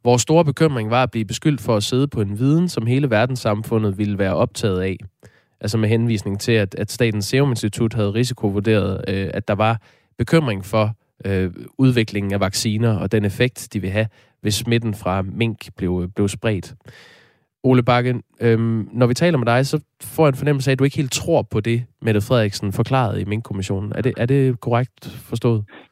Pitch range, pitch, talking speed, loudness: 105-125 Hz, 115 Hz, 185 wpm, -20 LUFS